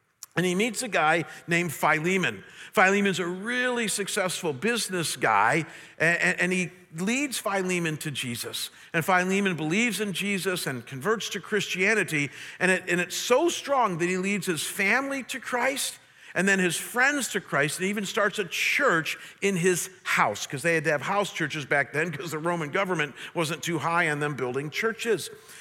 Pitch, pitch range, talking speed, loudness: 180 Hz, 160-205 Hz, 180 wpm, -26 LUFS